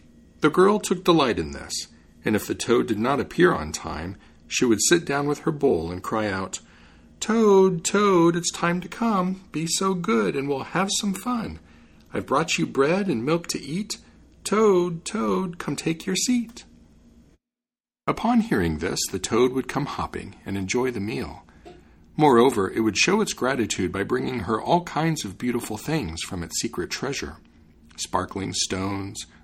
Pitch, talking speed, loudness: 140 Hz, 175 wpm, -24 LUFS